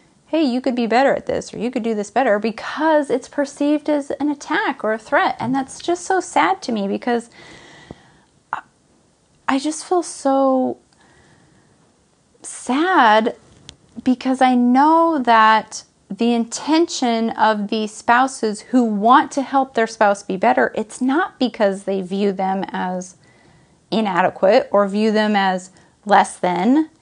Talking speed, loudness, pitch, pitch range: 145 wpm, -18 LUFS, 240 Hz, 210-285 Hz